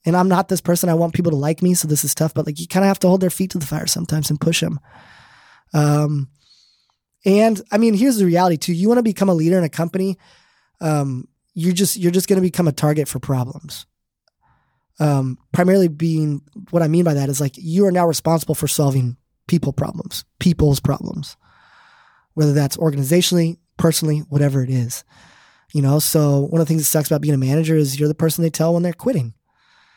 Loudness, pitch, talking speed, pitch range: -18 LUFS, 160 Hz, 220 wpm, 145-175 Hz